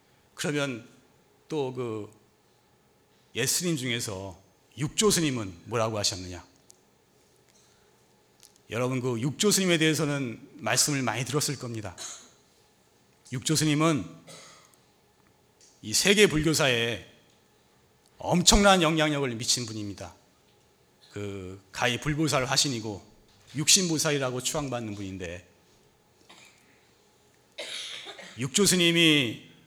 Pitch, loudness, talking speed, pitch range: 125 Hz, -25 LUFS, 205 characters per minute, 105-155 Hz